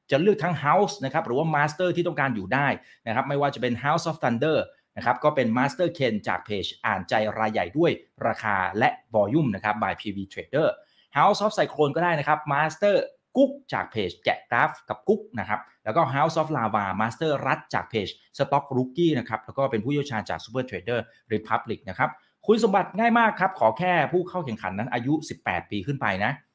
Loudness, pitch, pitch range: -25 LUFS, 140 Hz, 110-170 Hz